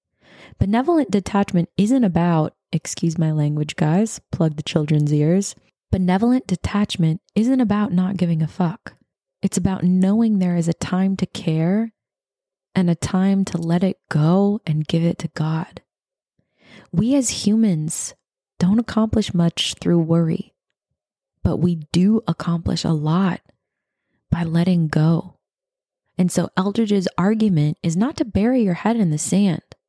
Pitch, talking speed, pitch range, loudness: 180 Hz, 145 wpm, 165-205 Hz, -20 LUFS